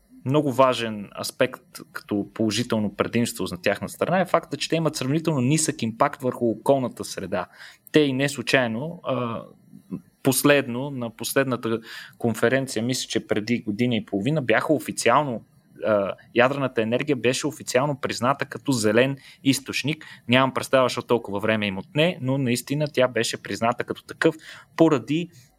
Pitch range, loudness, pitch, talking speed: 115-140 Hz, -24 LUFS, 125 Hz, 140 wpm